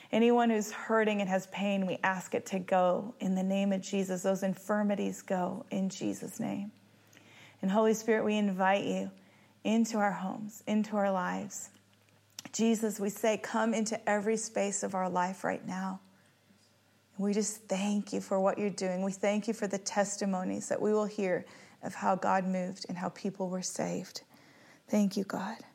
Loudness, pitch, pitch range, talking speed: -32 LUFS, 195 Hz, 180-210 Hz, 175 wpm